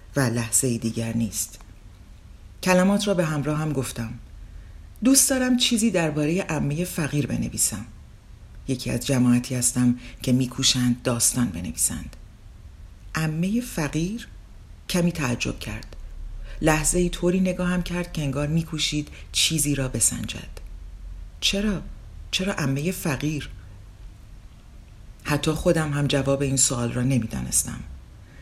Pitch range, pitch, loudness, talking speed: 105-160 Hz, 125 Hz, -23 LUFS, 115 wpm